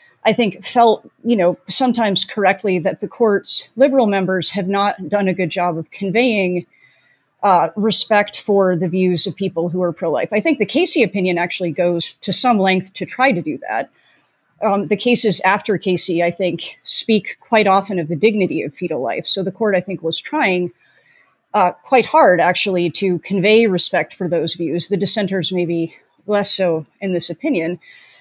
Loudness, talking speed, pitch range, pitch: -17 LUFS, 185 wpm, 180-215 Hz, 190 Hz